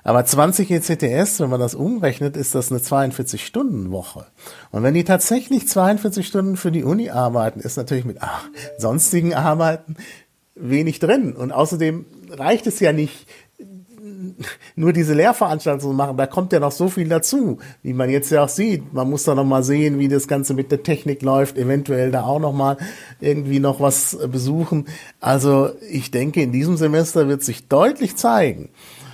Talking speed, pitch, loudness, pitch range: 175 wpm, 145 Hz, -19 LUFS, 135-175 Hz